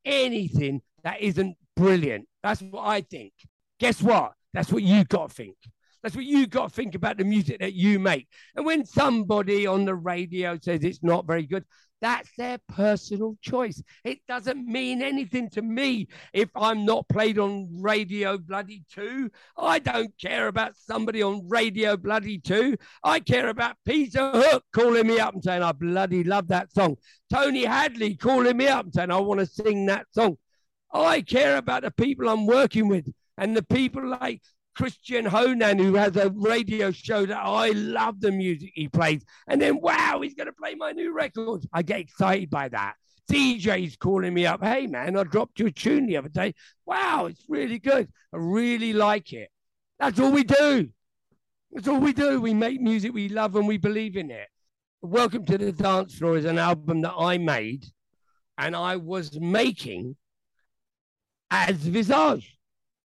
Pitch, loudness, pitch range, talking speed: 205 Hz, -25 LUFS, 180-235 Hz, 185 wpm